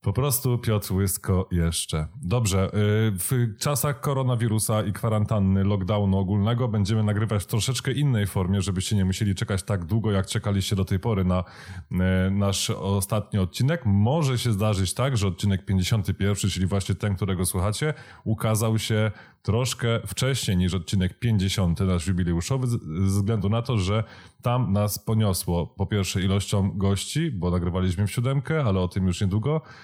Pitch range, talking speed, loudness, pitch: 95-115 Hz, 155 wpm, -25 LUFS, 105 Hz